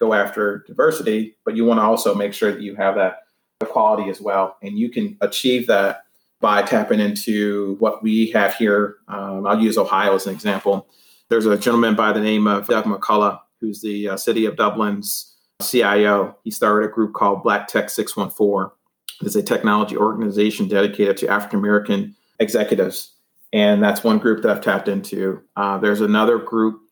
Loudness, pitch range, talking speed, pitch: -19 LUFS, 100-115 Hz, 180 wpm, 105 Hz